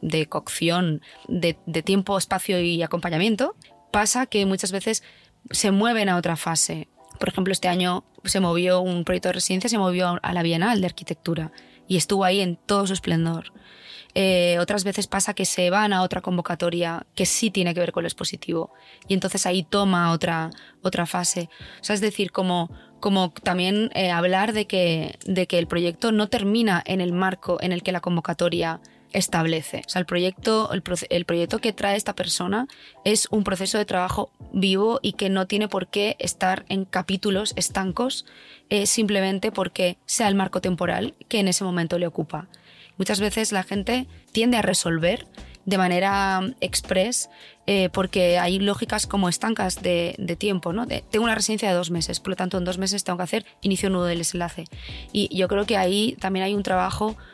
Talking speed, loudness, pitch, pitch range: 190 wpm, -23 LUFS, 190 Hz, 175-205 Hz